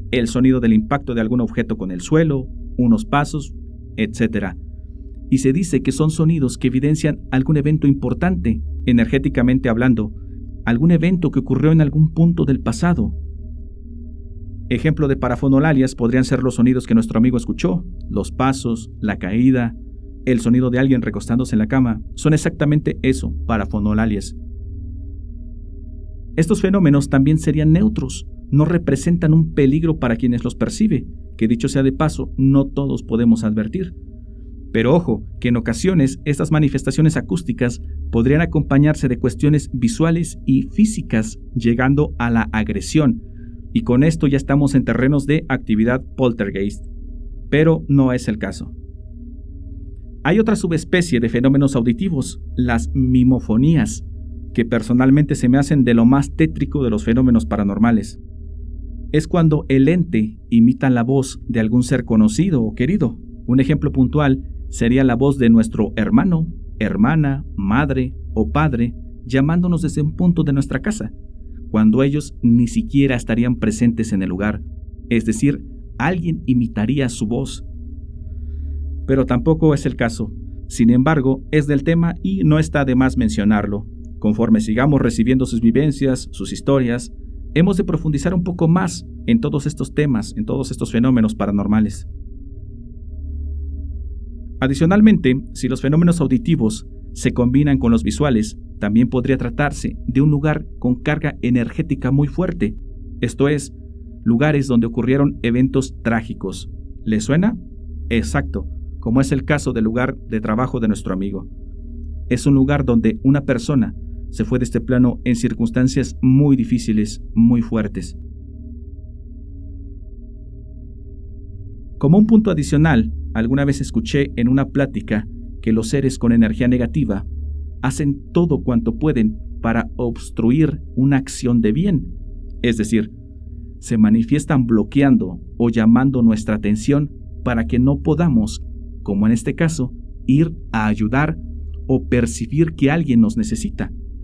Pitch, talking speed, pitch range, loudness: 120 Hz, 140 wpm, 95-140 Hz, -18 LUFS